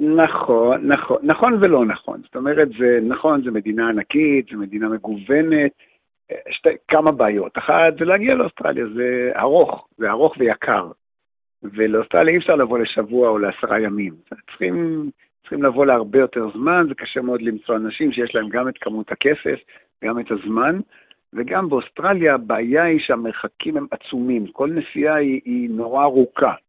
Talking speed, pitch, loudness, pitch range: 155 wpm, 130 Hz, -18 LUFS, 110-155 Hz